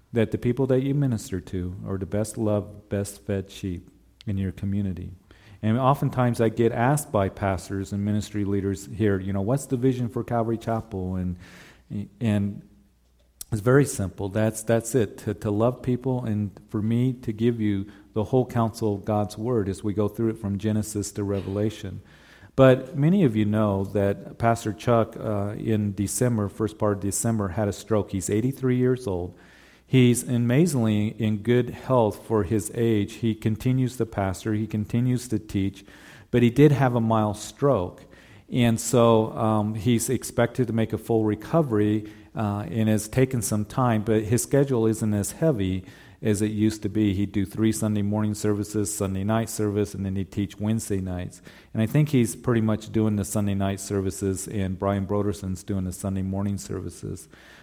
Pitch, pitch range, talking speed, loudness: 110 Hz, 100-115 Hz, 180 wpm, -25 LUFS